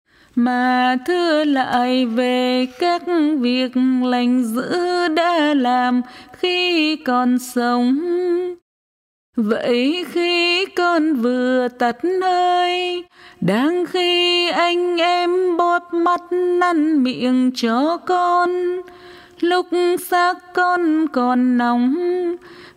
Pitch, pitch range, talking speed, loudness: 335 Hz, 250-355 Hz, 90 wpm, -18 LUFS